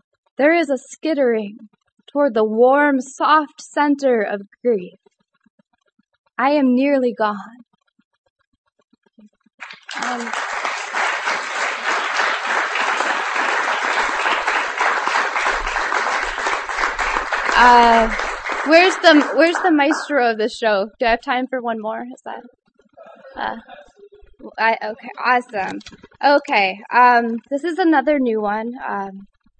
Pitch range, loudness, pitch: 220-280 Hz, -18 LUFS, 240 Hz